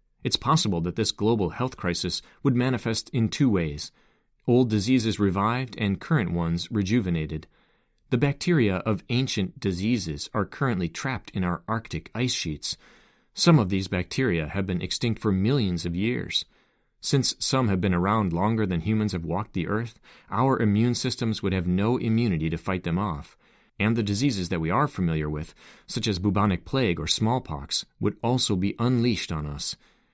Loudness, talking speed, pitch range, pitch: -26 LUFS, 170 wpm, 90-120 Hz, 105 Hz